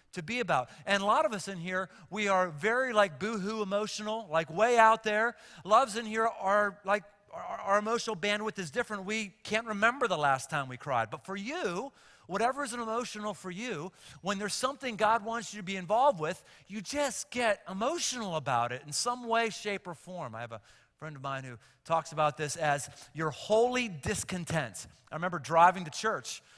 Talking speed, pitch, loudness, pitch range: 200 wpm, 205 Hz, -31 LUFS, 165-225 Hz